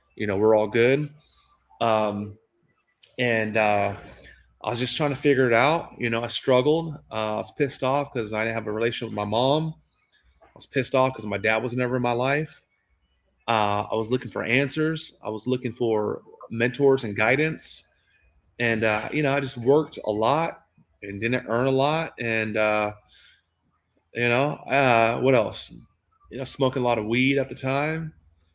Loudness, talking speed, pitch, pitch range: -24 LUFS, 190 wpm, 120 Hz, 110-135 Hz